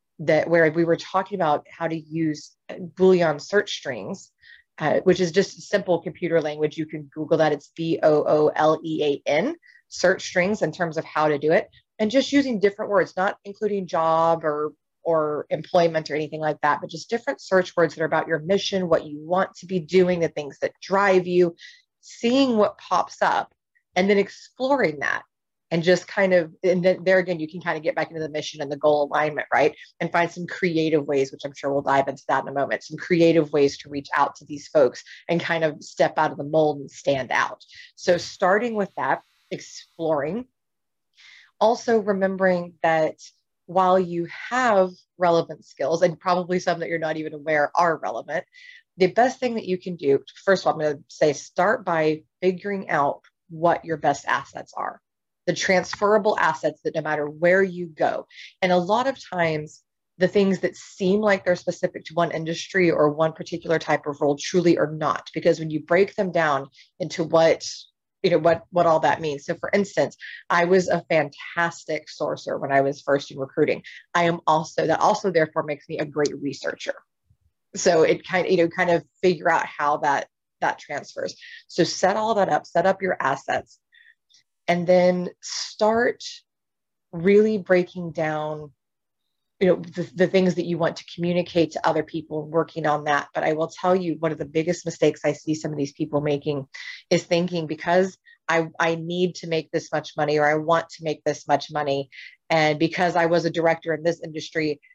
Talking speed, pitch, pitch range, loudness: 200 wpm, 165 Hz, 155-185 Hz, -23 LUFS